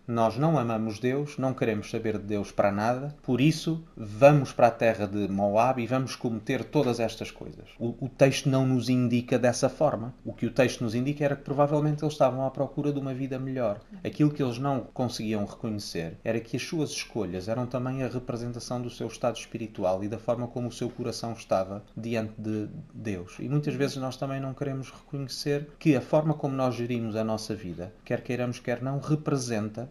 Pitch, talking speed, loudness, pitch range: 125 Hz, 205 wpm, -28 LUFS, 115-140 Hz